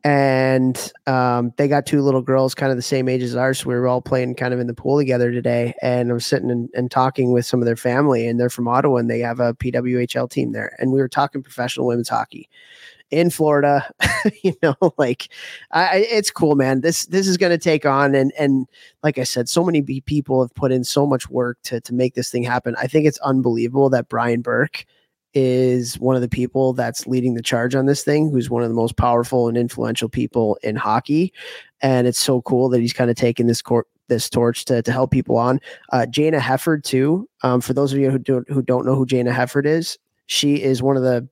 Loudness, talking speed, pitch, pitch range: -19 LUFS, 235 wpm, 130 Hz, 120-140 Hz